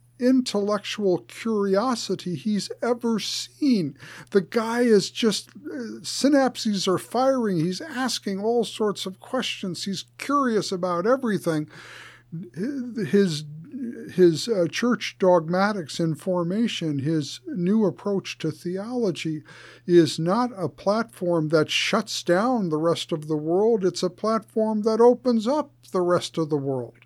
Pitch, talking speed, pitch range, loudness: 190 Hz, 125 wpm, 165-225 Hz, -24 LUFS